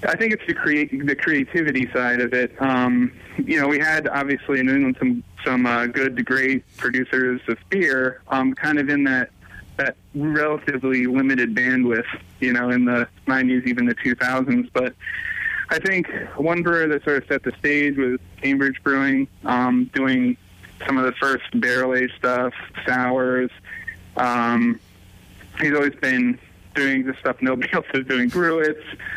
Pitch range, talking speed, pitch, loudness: 125-145 Hz, 165 wpm, 130 Hz, -21 LUFS